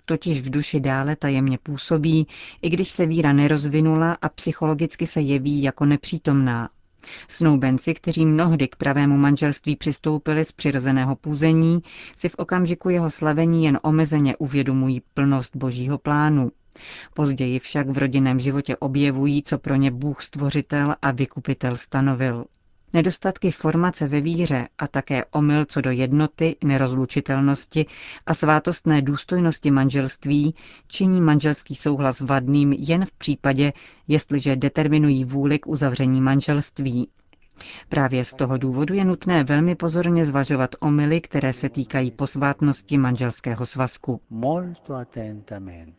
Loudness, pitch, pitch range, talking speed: -21 LUFS, 145 Hz, 135-155 Hz, 125 wpm